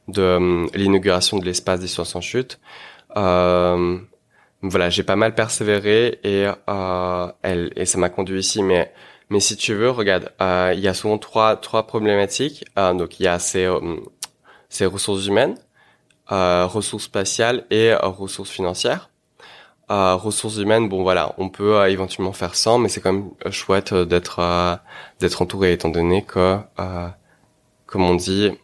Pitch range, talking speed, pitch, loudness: 90-105 Hz, 170 wpm, 95 Hz, -19 LUFS